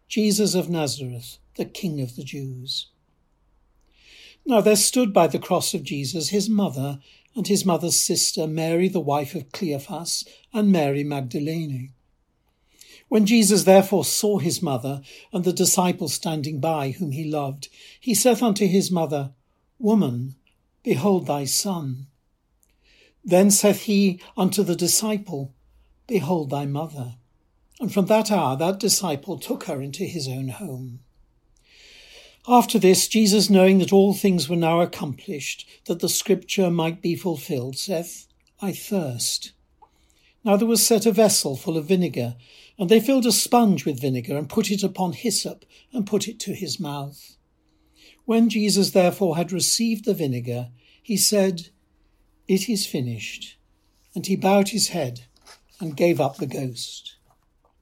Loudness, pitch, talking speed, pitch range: -21 LUFS, 175 Hz, 145 wpm, 140-200 Hz